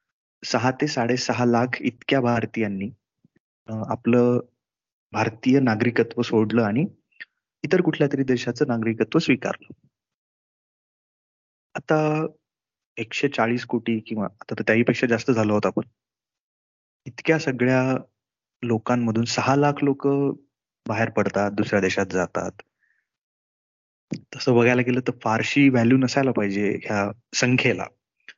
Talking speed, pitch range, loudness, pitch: 110 wpm, 110-135 Hz, -22 LUFS, 120 Hz